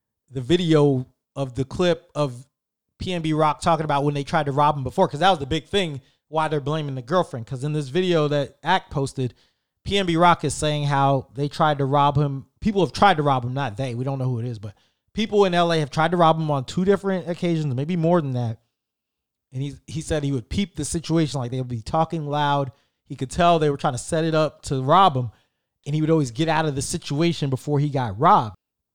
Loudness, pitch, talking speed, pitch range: -22 LUFS, 150 Hz, 245 wpm, 135-165 Hz